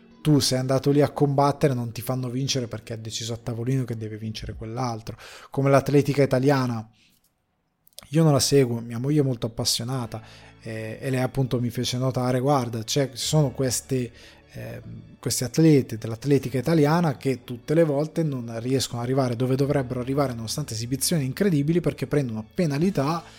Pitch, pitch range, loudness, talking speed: 130 Hz, 115-145 Hz, -24 LUFS, 160 wpm